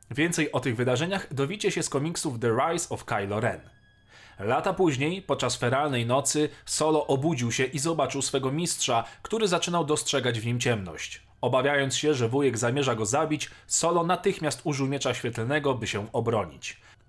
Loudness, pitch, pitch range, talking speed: -27 LUFS, 140 Hz, 120-155 Hz, 160 wpm